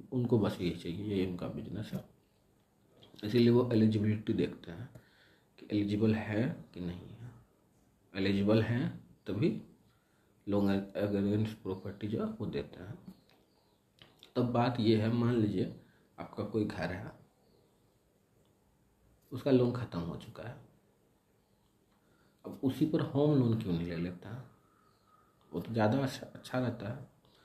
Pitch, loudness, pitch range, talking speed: 110 Hz, -33 LUFS, 95-120 Hz, 140 wpm